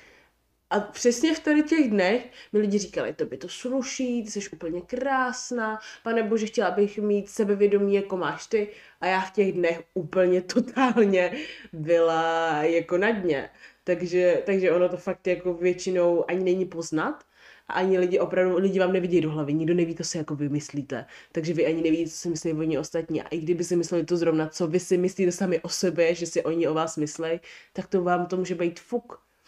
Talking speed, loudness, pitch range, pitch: 200 wpm, -25 LUFS, 170-205 Hz, 180 Hz